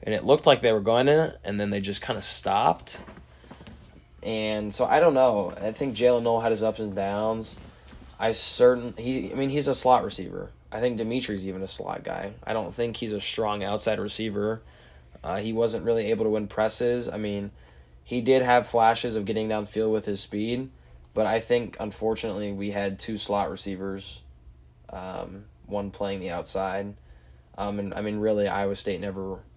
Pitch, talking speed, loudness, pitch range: 105 Hz, 190 wpm, -26 LUFS, 100-115 Hz